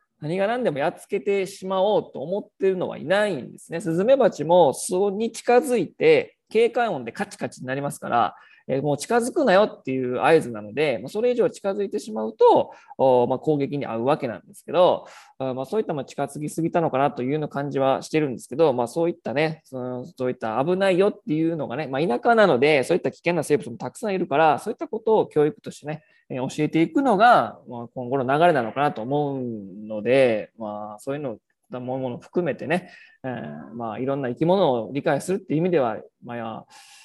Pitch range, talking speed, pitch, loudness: 130-195 Hz, 390 characters per minute, 155 Hz, -23 LUFS